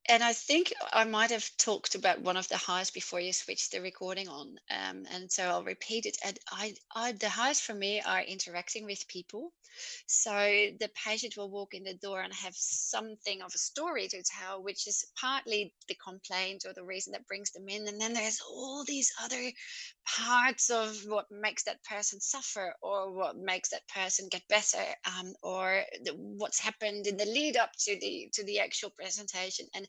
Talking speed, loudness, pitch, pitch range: 200 wpm, -33 LUFS, 205 Hz, 190-230 Hz